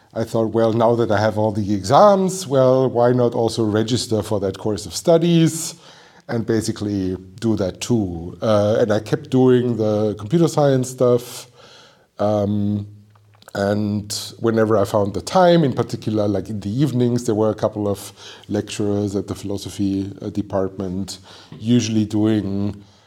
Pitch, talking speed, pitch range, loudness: 110 Hz, 155 wpm, 100-120 Hz, -19 LUFS